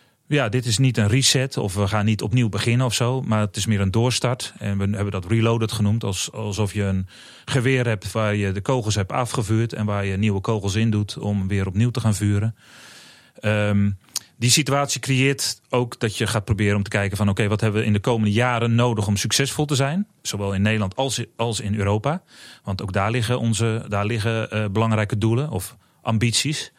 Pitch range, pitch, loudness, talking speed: 105-125 Hz, 110 Hz, -22 LUFS, 215 wpm